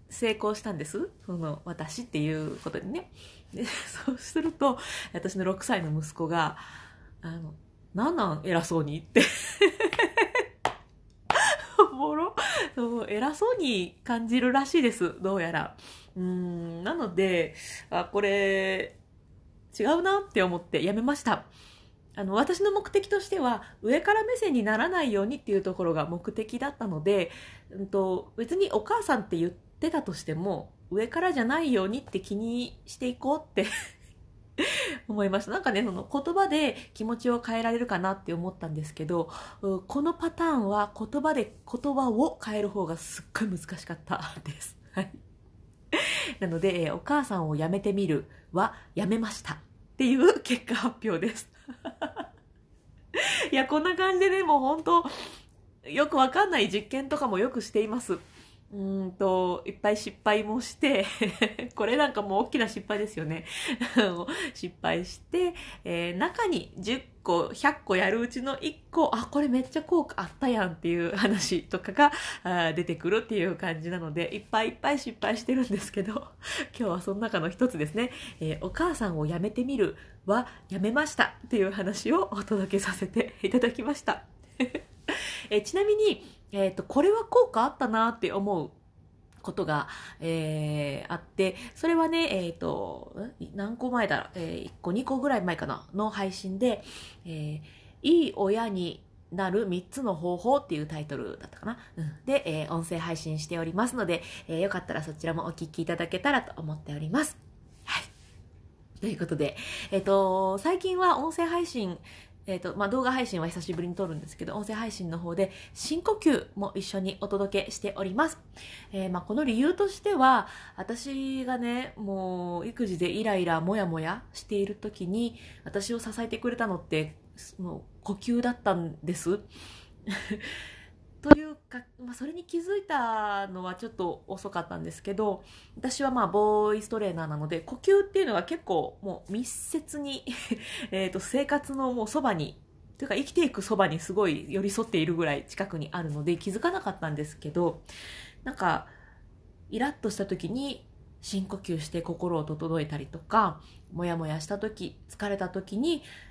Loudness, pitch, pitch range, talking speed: -29 LUFS, 205 Hz, 175-265 Hz, 320 characters per minute